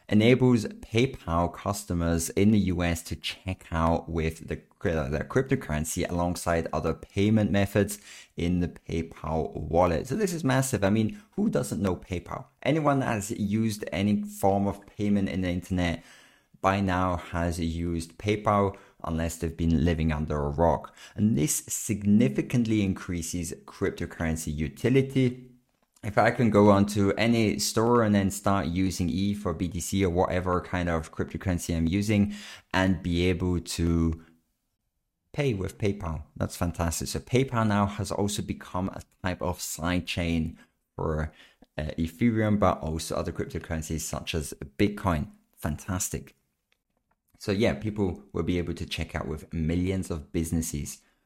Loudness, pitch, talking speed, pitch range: -27 LUFS, 90 Hz, 145 wpm, 85-105 Hz